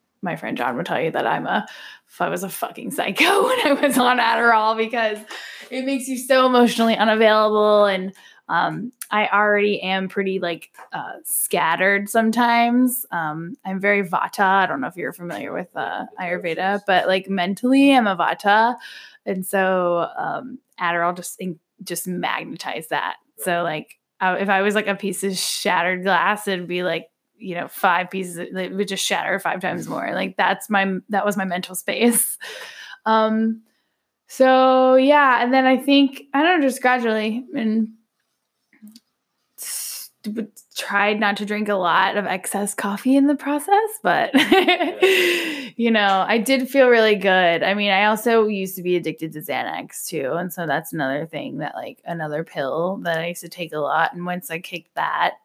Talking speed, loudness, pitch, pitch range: 175 wpm, -20 LUFS, 205 Hz, 185-245 Hz